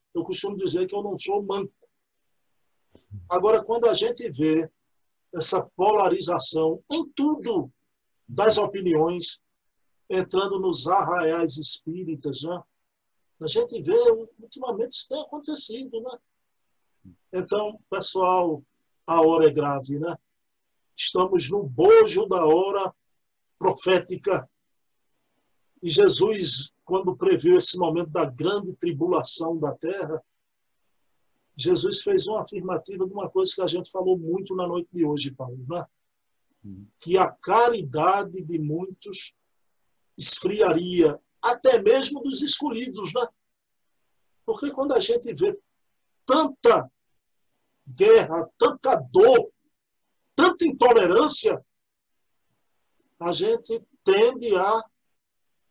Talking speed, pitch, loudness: 110 wpm, 195 Hz, -23 LUFS